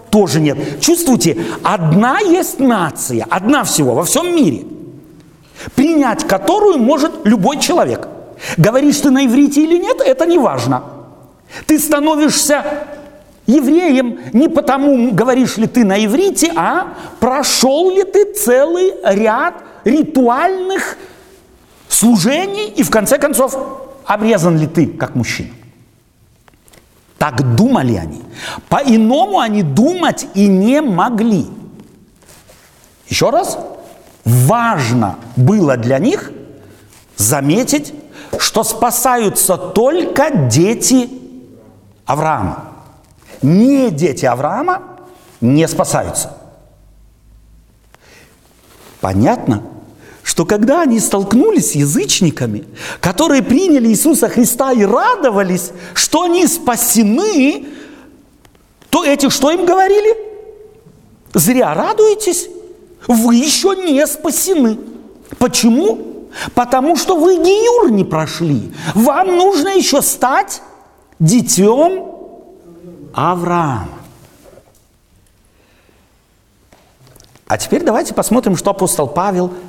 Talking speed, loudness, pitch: 95 wpm, -13 LUFS, 245 Hz